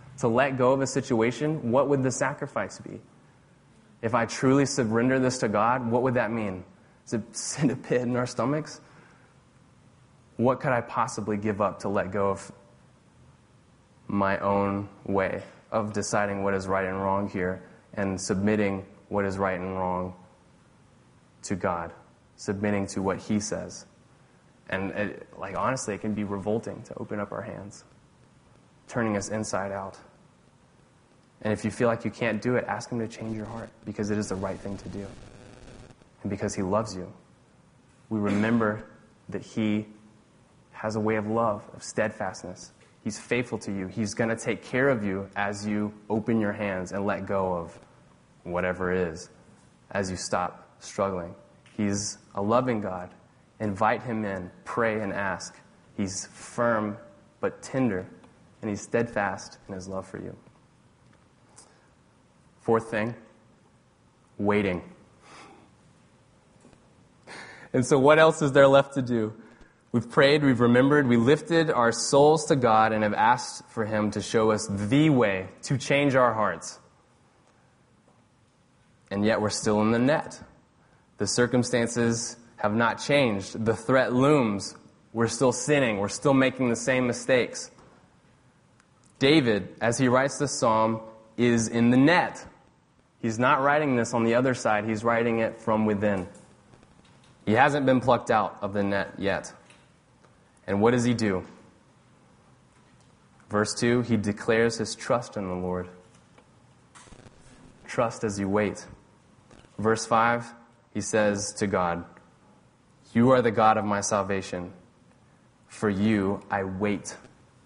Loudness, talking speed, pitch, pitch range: -26 LUFS, 150 wpm, 110 Hz, 100-120 Hz